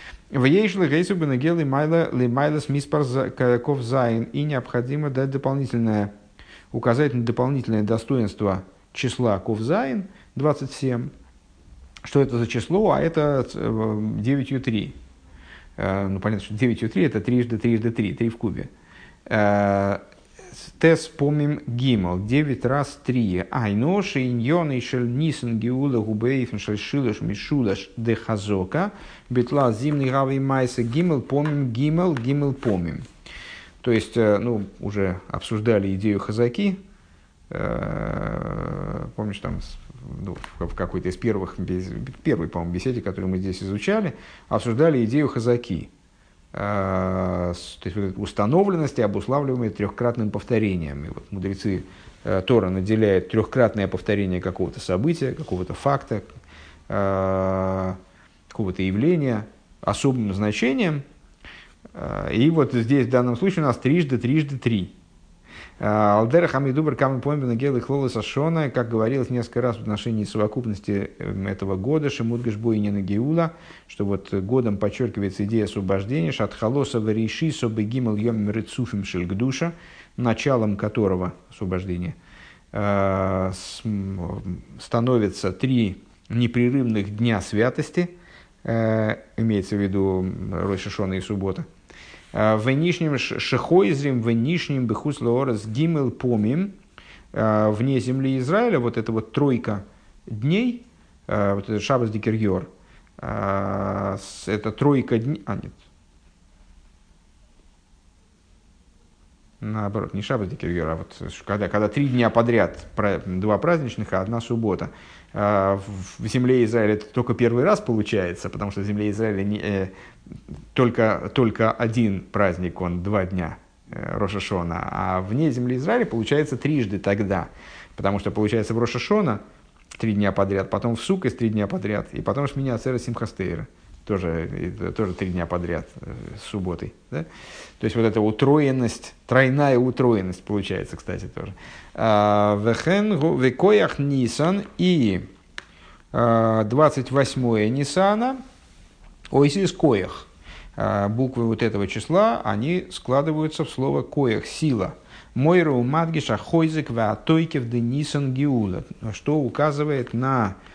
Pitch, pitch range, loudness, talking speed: 115 Hz, 100-135 Hz, -23 LUFS, 110 wpm